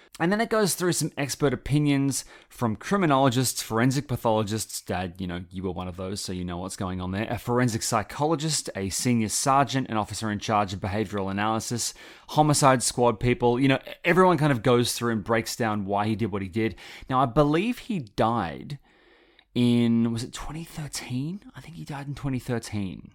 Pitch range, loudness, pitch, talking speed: 105-140 Hz, -25 LUFS, 120 Hz, 190 wpm